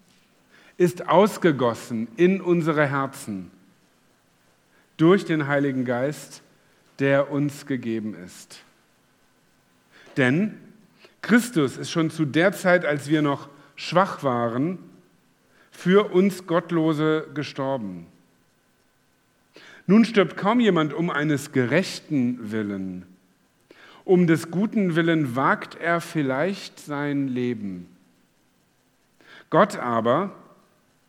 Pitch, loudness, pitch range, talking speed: 150 Hz, -23 LUFS, 125-180 Hz, 95 wpm